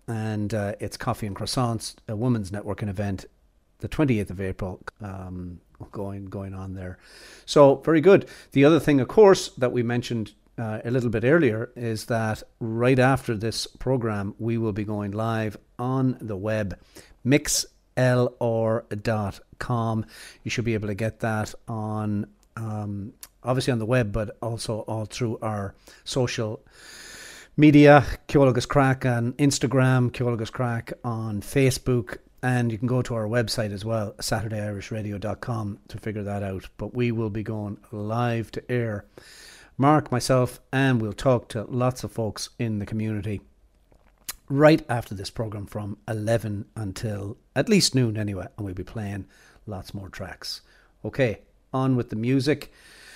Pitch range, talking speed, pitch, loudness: 105-125 Hz, 150 wpm, 115 Hz, -24 LUFS